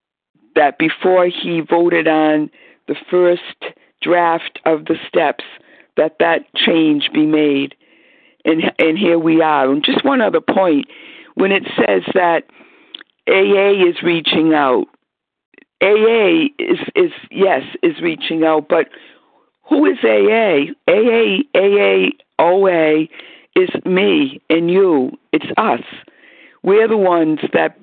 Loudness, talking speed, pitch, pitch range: -14 LUFS, 125 wpm, 175 Hz, 160-235 Hz